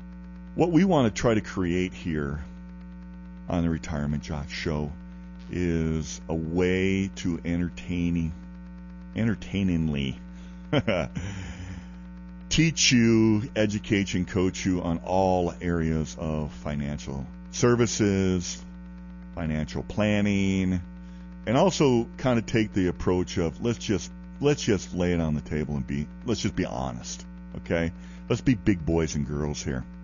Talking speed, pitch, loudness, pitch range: 130 wpm, 85 Hz, -26 LUFS, 60-95 Hz